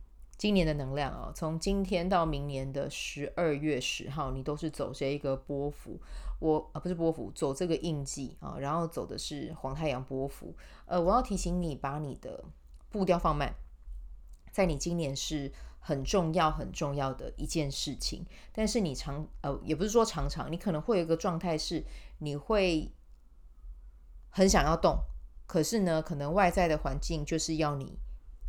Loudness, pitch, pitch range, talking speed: -32 LUFS, 150 Hz, 135-170 Hz, 255 characters per minute